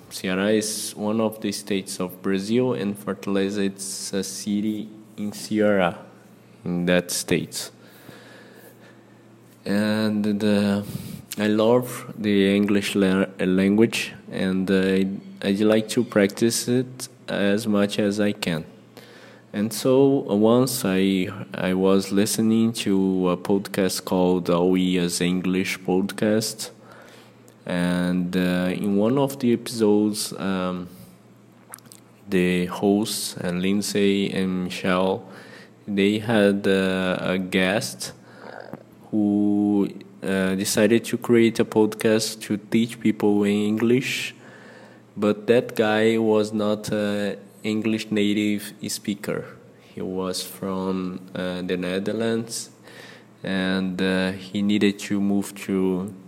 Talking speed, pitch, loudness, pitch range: 115 wpm, 100 Hz, -23 LUFS, 95-110 Hz